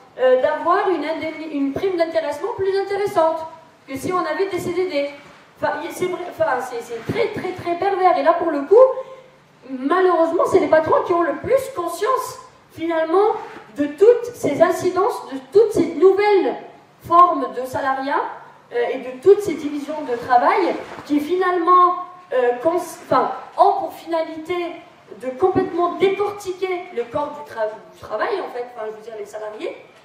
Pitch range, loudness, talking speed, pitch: 295-380 Hz, -19 LUFS, 170 wpm, 345 Hz